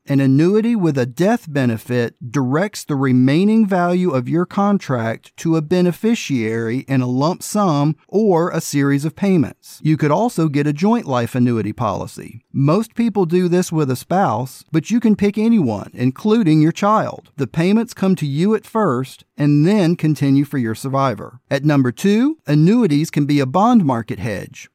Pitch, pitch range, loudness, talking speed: 155 Hz, 130-195 Hz, -17 LUFS, 175 wpm